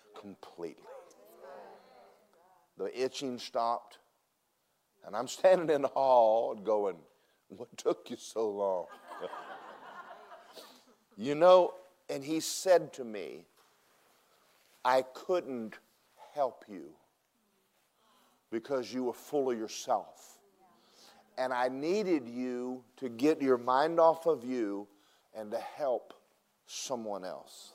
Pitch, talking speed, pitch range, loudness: 130 Hz, 105 wpm, 120-155 Hz, -32 LUFS